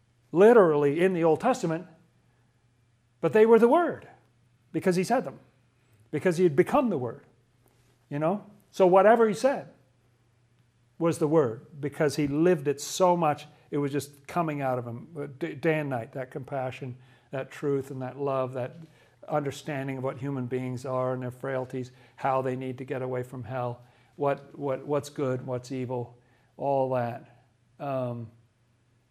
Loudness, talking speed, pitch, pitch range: -27 LUFS, 165 wpm, 135 Hz, 125-155 Hz